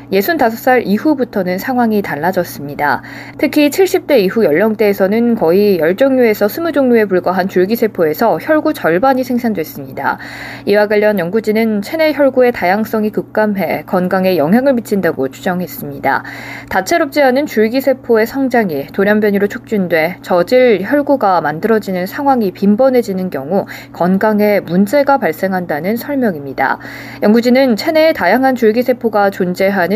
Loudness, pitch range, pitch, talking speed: -13 LUFS, 180-250 Hz, 210 Hz, 335 characters per minute